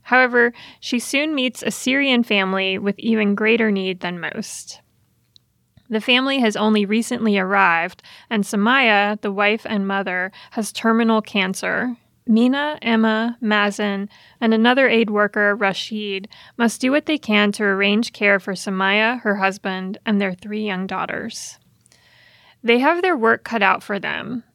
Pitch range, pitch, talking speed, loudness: 200-240 Hz, 215 Hz, 150 wpm, -19 LUFS